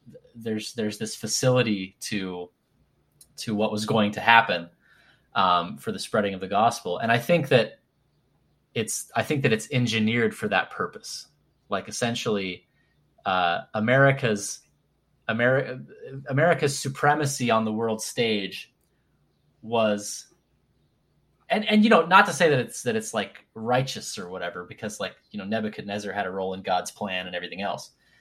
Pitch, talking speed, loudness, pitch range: 110 Hz, 155 wpm, -25 LUFS, 105-125 Hz